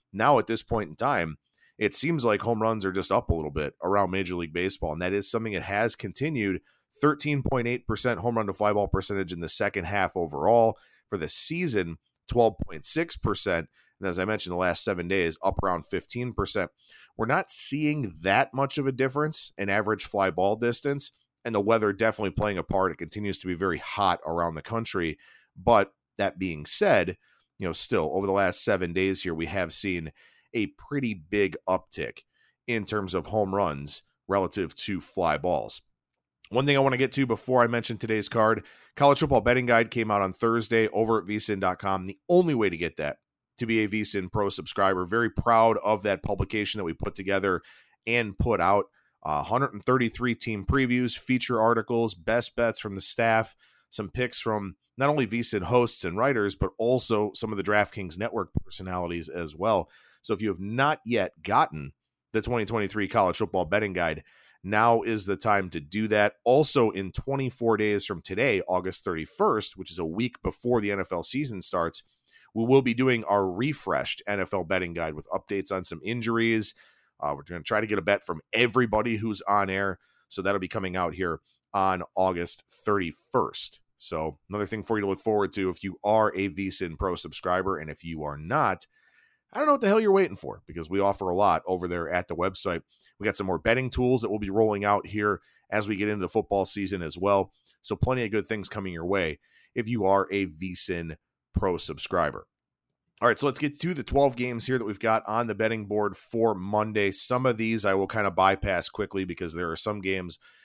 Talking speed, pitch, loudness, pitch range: 200 wpm, 105 Hz, -27 LUFS, 95-115 Hz